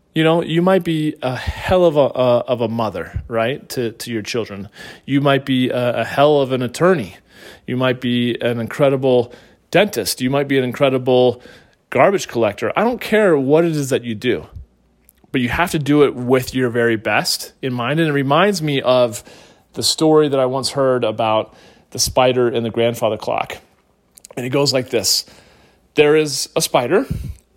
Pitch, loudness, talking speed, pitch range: 130 Hz, -17 LUFS, 190 wpm, 120-145 Hz